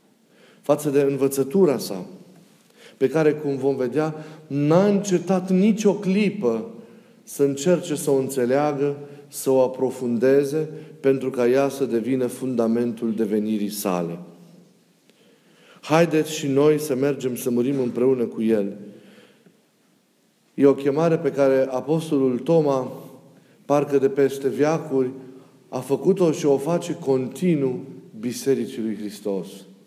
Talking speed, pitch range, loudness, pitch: 120 wpm, 130-160 Hz, -22 LUFS, 140 Hz